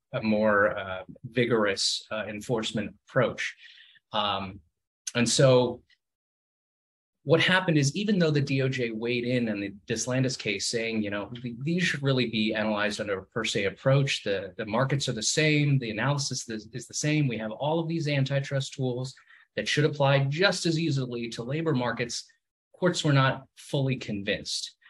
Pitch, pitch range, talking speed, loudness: 125 Hz, 110-145 Hz, 165 wpm, -27 LUFS